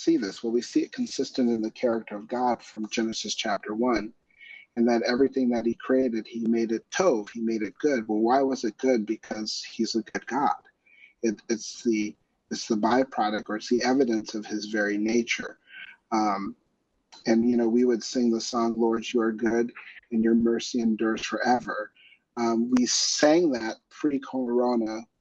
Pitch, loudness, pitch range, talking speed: 115 Hz, -26 LUFS, 110-125 Hz, 185 wpm